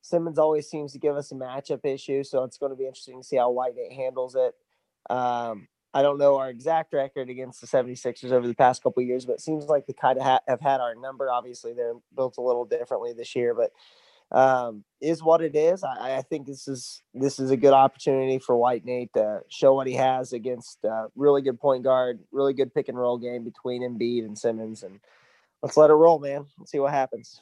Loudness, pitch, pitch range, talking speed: -25 LUFS, 135 Hz, 125-155 Hz, 230 wpm